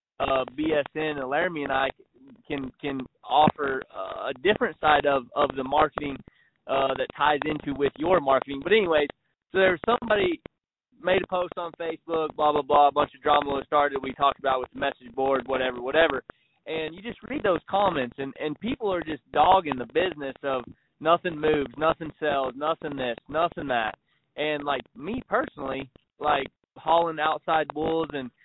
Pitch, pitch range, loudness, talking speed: 150 Hz, 135-165 Hz, -26 LUFS, 180 wpm